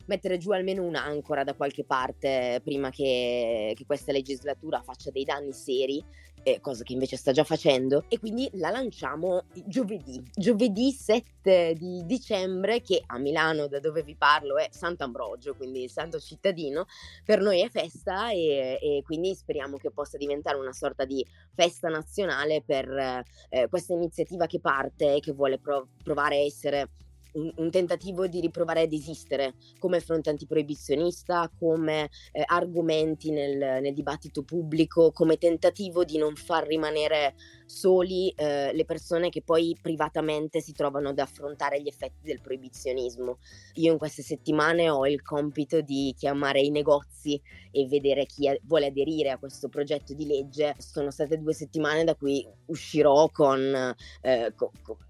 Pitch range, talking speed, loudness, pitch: 140-165 Hz, 155 wpm, -28 LUFS, 150 Hz